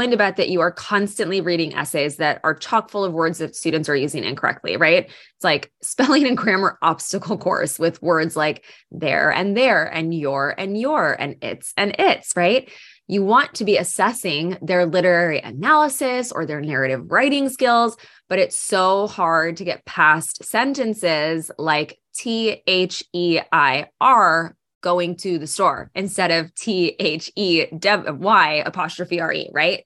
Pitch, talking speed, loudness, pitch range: 180 Hz, 165 wpm, -19 LUFS, 160-210 Hz